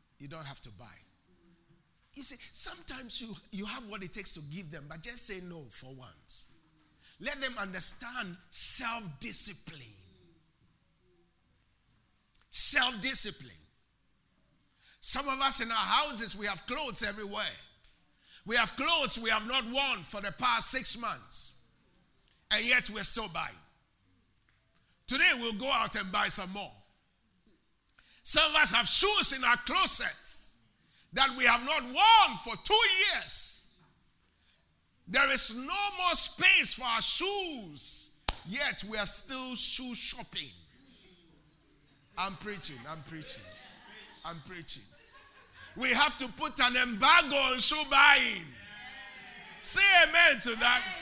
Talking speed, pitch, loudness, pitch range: 135 wpm, 230 Hz, -24 LUFS, 175-270 Hz